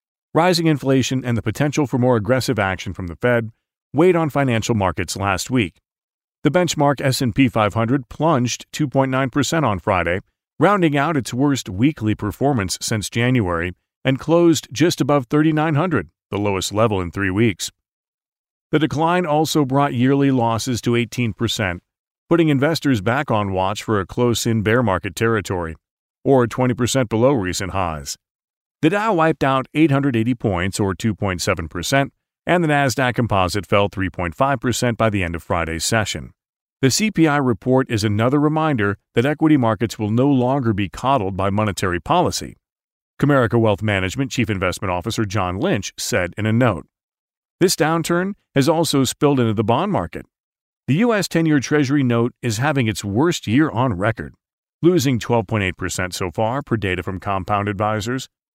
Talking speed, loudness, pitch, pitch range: 155 wpm, -19 LUFS, 120 Hz, 105-140 Hz